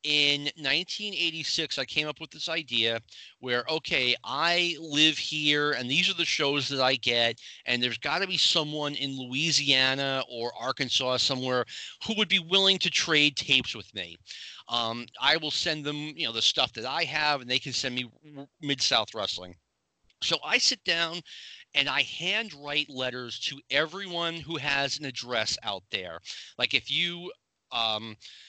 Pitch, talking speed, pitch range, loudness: 145 Hz, 170 wpm, 125-160 Hz, -26 LUFS